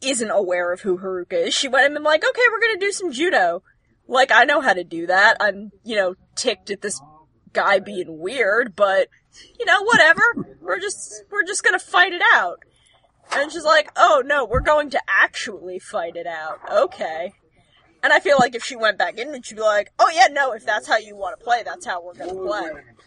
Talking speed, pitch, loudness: 220 wpm, 230 Hz, -19 LUFS